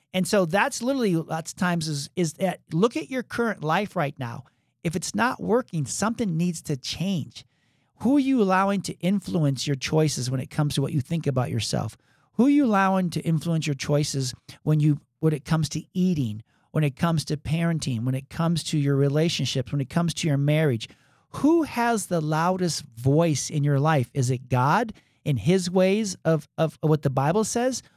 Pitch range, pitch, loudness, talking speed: 140-185 Hz, 160 Hz, -25 LUFS, 200 wpm